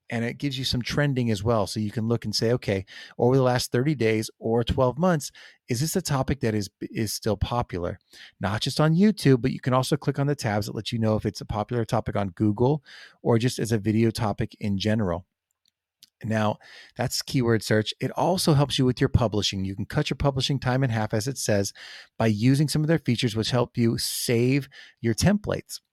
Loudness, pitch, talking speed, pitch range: -25 LUFS, 120 Hz, 225 wpm, 110-135 Hz